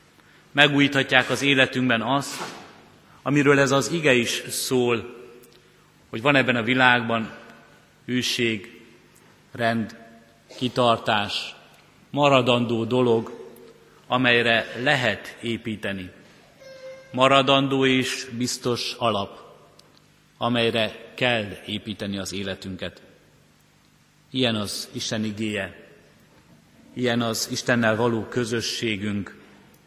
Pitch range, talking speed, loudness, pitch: 110-130 Hz, 80 wpm, -22 LUFS, 120 Hz